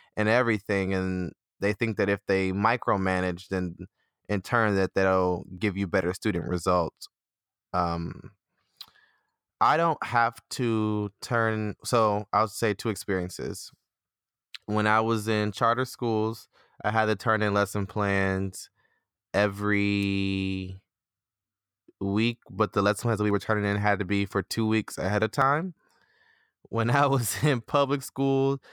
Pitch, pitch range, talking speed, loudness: 105 Hz, 95-115 Hz, 145 wpm, -27 LUFS